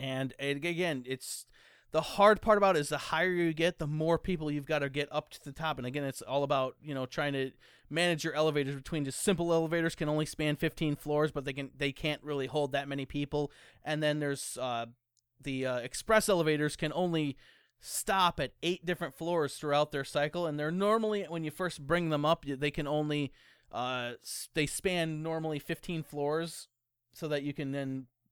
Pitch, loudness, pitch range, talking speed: 150 Hz, -32 LUFS, 140-165 Hz, 205 wpm